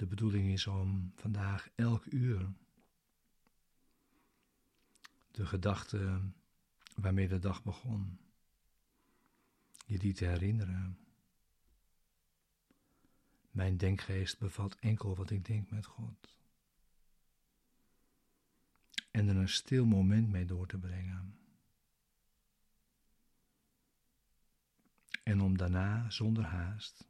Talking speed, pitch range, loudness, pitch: 90 wpm, 95-105 Hz, -36 LUFS, 100 Hz